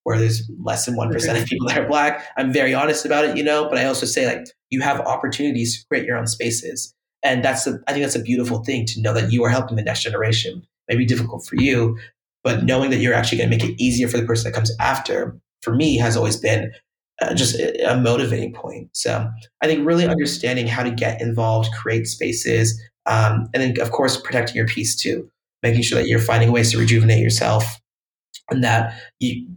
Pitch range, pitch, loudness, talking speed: 115-130 Hz, 120 Hz, -19 LUFS, 225 wpm